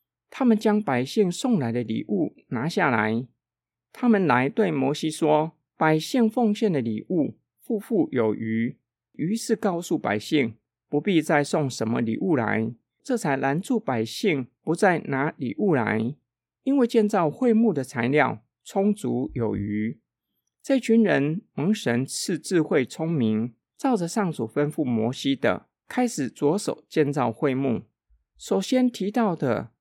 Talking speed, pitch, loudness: 205 characters per minute, 150 Hz, -24 LUFS